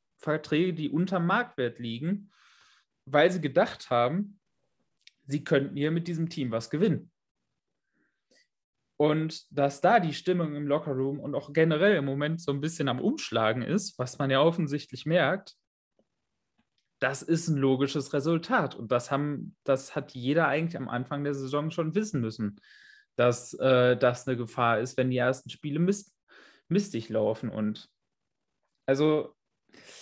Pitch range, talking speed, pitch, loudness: 130-165 Hz, 150 wpm, 145 Hz, -28 LUFS